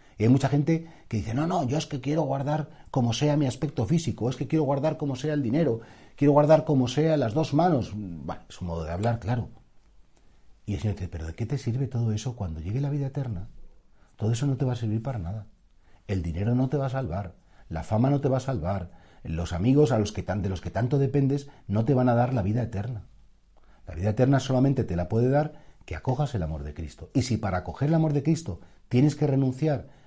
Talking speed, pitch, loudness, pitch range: 245 wpm, 120 Hz, -27 LUFS, 100-140 Hz